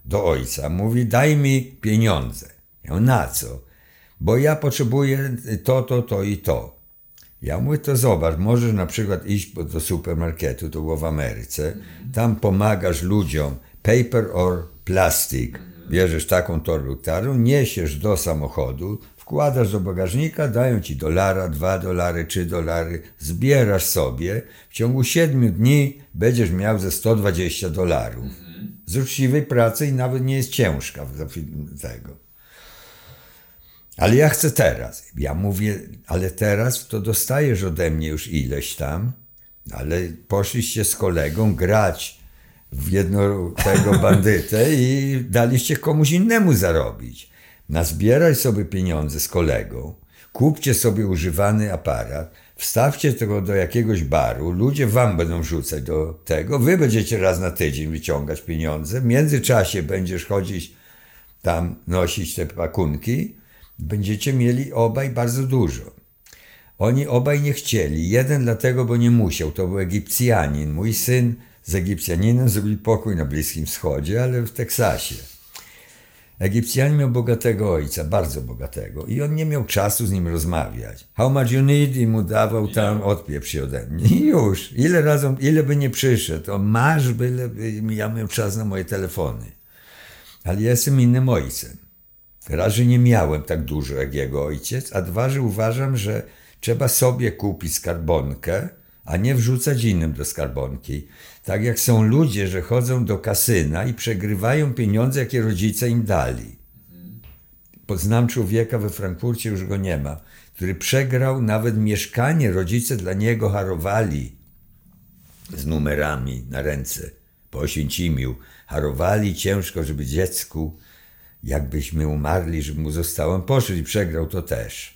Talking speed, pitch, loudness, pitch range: 140 wpm, 100 Hz, -20 LUFS, 80-120 Hz